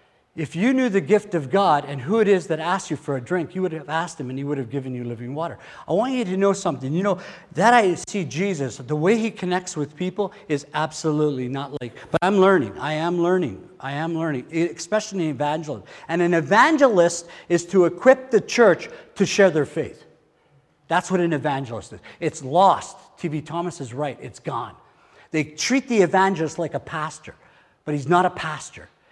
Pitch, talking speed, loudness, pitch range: 170 Hz, 210 wpm, -22 LUFS, 150-195 Hz